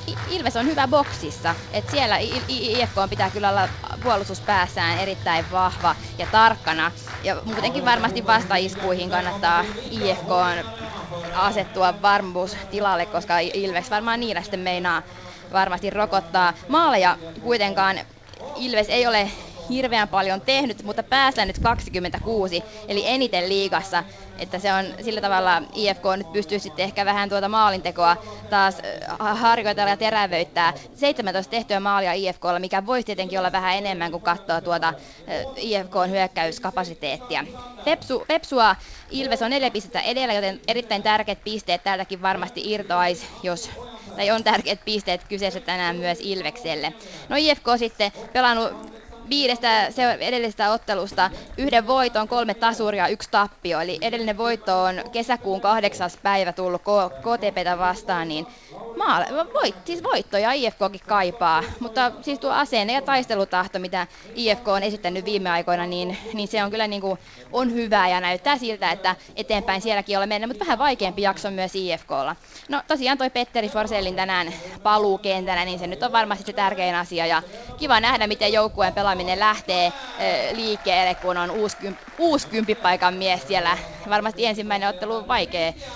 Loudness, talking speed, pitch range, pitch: -22 LUFS, 145 wpm, 185-225 Hz, 200 Hz